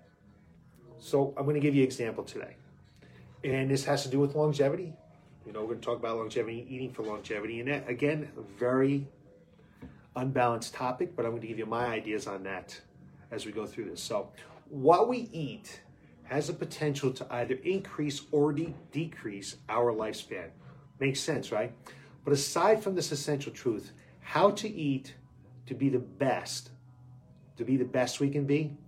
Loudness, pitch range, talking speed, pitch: -31 LUFS, 120-150 Hz, 175 wpm, 135 Hz